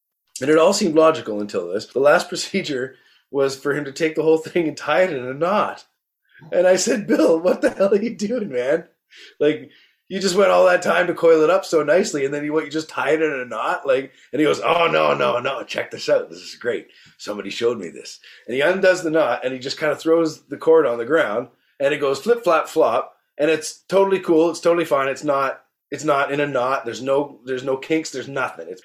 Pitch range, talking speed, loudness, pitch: 140-195 Hz, 250 wpm, -20 LUFS, 160 Hz